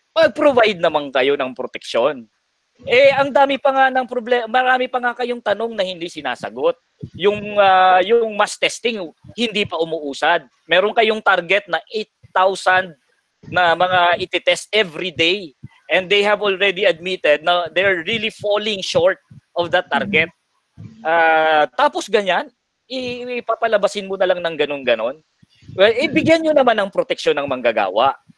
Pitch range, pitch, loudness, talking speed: 175-245 Hz, 205 Hz, -17 LUFS, 145 wpm